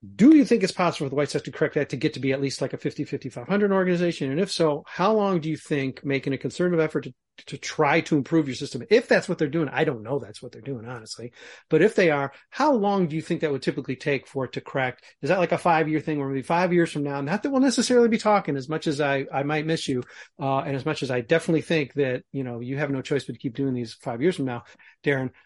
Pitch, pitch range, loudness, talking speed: 150 Hz, 135-170 Hz, -24 LUFS, 290 wpm